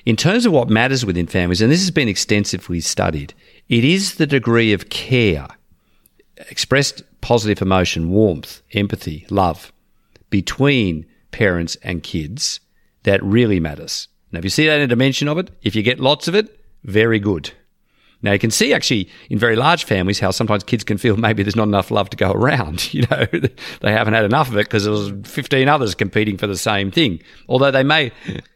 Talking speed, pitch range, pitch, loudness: 195 wpm, 95-130 Hz, 105 Hz, -17 LUFS